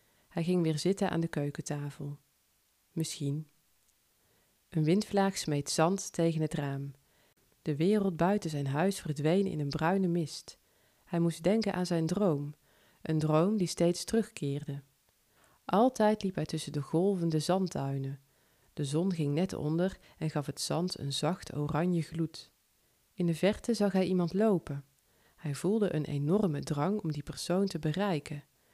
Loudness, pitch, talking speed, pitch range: -32 LUFS, 160 Hz, 150 wpm, 145-185 Hz